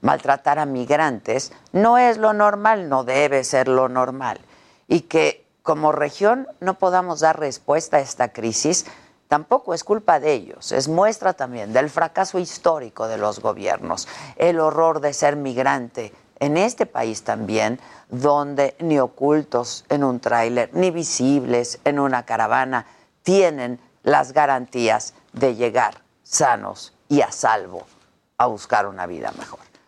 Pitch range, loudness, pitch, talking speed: 125-165 Hz, -20 LUFS, 145 Hz, 145 wpm